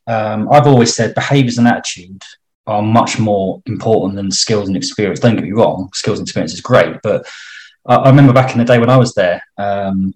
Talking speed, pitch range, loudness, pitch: 220 wpm, 100-125 Hz, -13 LUFS, 115 Hz